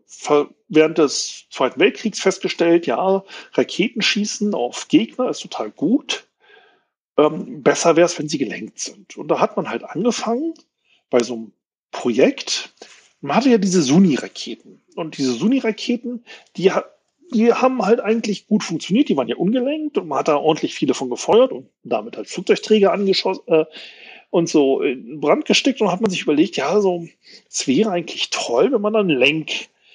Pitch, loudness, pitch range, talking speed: 215 Hz, -19 LUFS, 170-245 Hz, 170 wpm